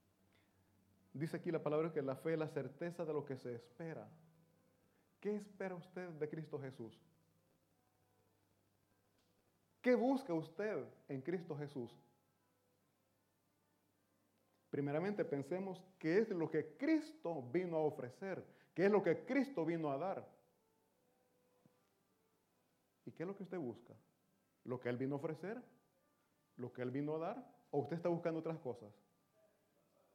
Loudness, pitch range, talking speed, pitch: -42 LUFS, 120-175 Hz, 140 wpm, 155 Hz